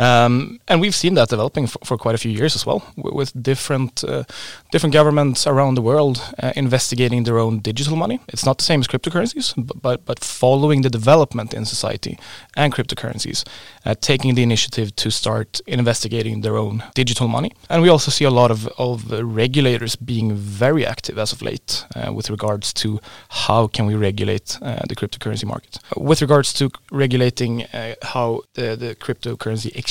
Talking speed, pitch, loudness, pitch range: 195 wpm, 125 Hz, -19 LUFS, 110-140 Hz